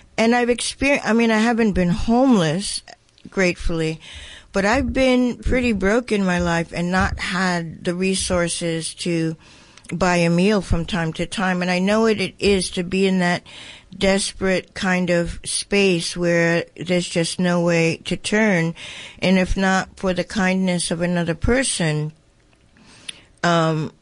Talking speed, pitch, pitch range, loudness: 155 wpm, 180 Hz, 170-200 Hz, -20 LUFS